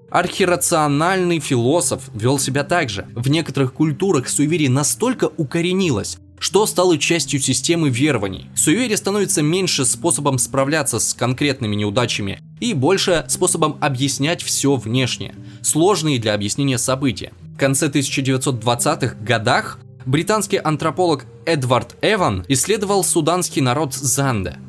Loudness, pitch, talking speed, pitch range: -18 LUFS, 140 Hz, 115 wpm, 125-165 Hz